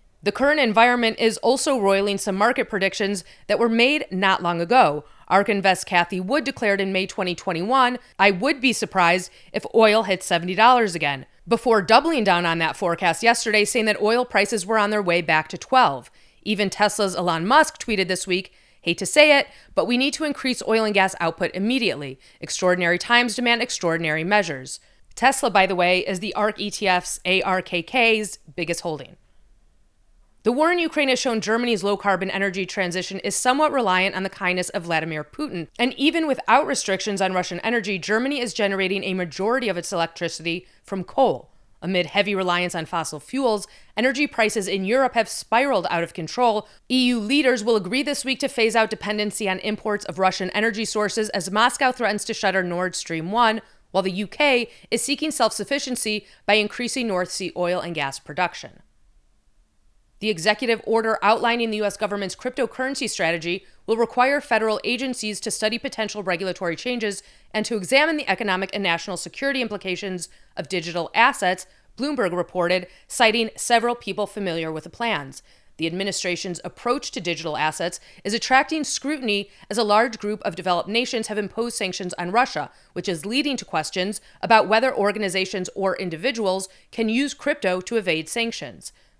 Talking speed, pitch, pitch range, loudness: 170 wpm, 205 Hz, 180-235 Hz, -22 LUFS